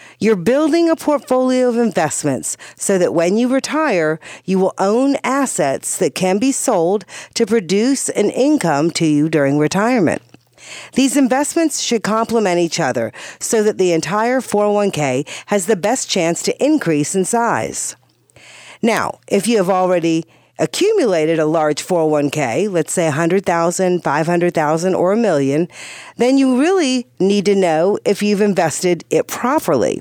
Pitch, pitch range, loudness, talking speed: 200 Hz, 165-250 Hz, -16 LUFS, 145 wpm